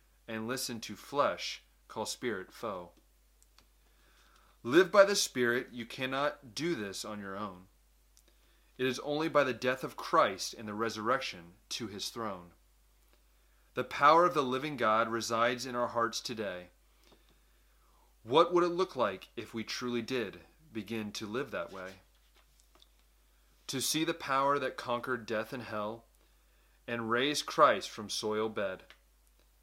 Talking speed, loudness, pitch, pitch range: 145 wpm, -32 LUFS, 115 Hz, 100-130 Hz